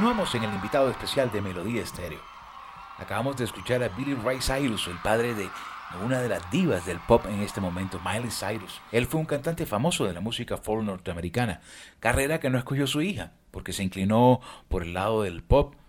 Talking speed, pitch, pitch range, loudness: 200 wpm, 110 Hz, 95-130 Hz, -27 LUFS